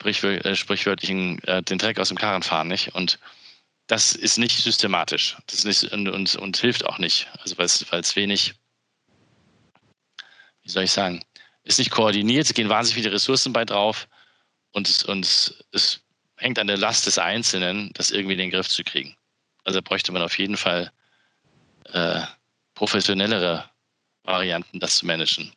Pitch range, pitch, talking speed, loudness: 90-110 Hz, 100 Hz, 165 wpm, -21 LUFS